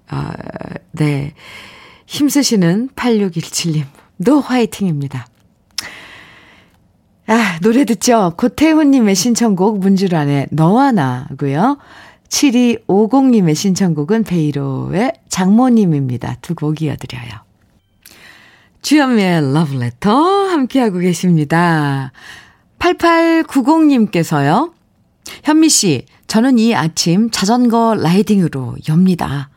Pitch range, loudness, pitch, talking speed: 145-240 Hz, -14 LUFS, 190 Hz, 200 characters per minute